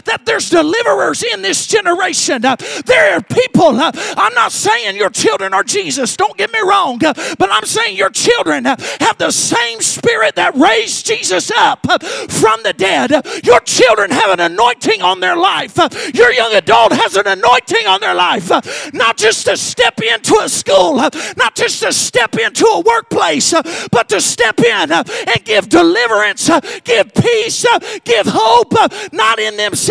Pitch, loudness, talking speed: 390 Hz, -11 LUFS, 165 wpm